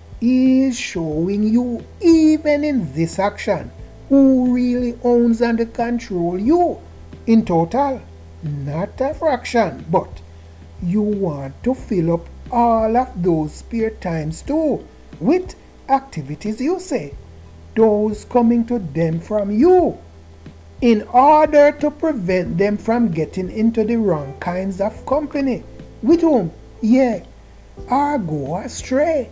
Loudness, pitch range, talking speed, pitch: -18 LUFS, 165-260 Hz, 120 wpm, 225 Hz